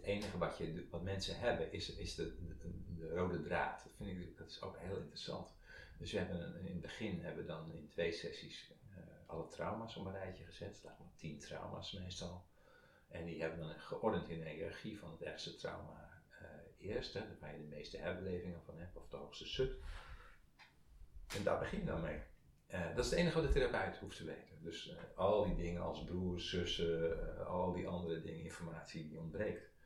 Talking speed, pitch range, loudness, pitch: 205 wpm, 80-90 Hz, -44 LUFS, 85 Hz